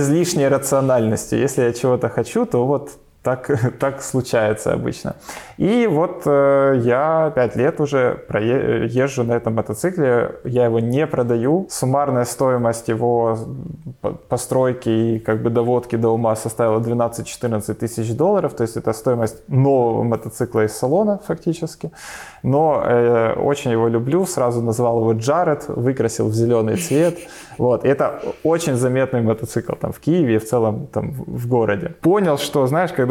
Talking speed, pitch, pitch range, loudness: 160 wpm, 125 Hz, 115-145 Hz, -19 LUFS